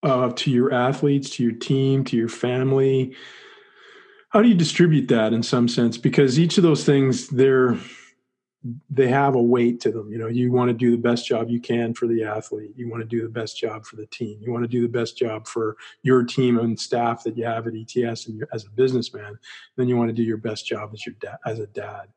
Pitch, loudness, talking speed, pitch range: 120 Hz, -21 LUFS, 245 wpm, 115-135 Hz